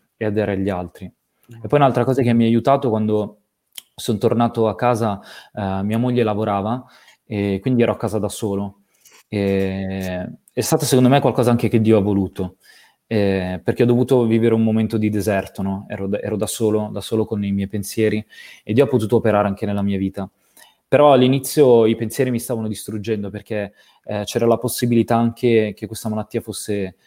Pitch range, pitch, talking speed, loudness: 100-120 Hz, 110 Hz, 190 wpm, -19 LUFS